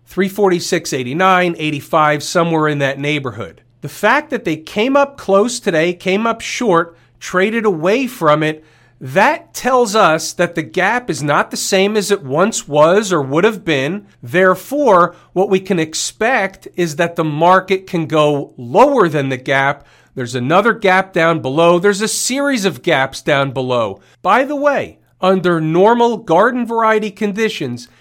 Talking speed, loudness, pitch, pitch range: 160 wpm, -15 LUFS, 175 Hz, 150-210 Hz